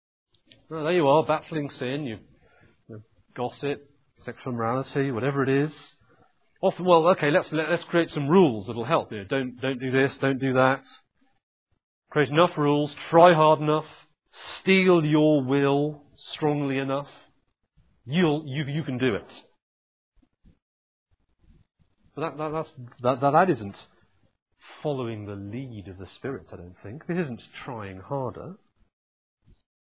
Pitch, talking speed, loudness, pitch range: 135 Hz, 145 wpm, -24 LUFS, 115-155 Hz